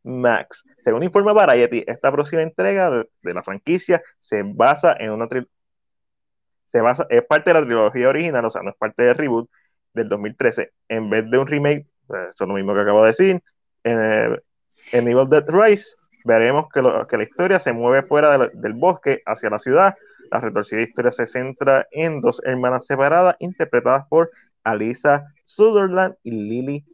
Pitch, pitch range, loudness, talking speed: 135 Hz, 115-160 Hz, -18 LUFS, 185 wpm